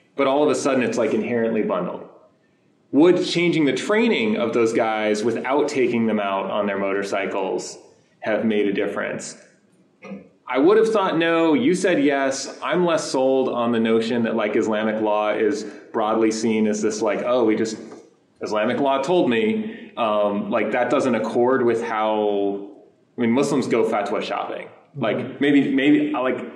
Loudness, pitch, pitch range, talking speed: -21 LUFS, 115 Hz, 105-145 Hz, 170 wpm